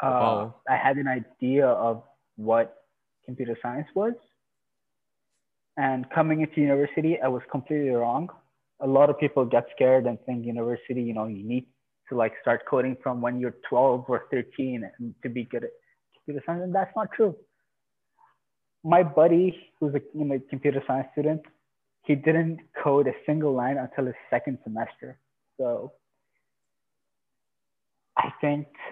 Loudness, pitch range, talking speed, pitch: -26 LUFS, 125-155 Hz, 155 wpm, 135 Hz